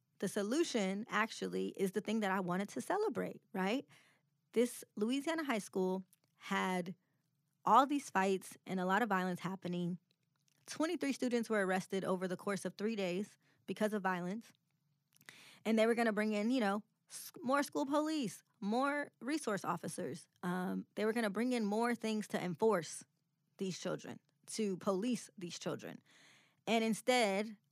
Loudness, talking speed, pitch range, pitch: -37 LUFS, 155 wpm, 180-225 Hz, 195 Hz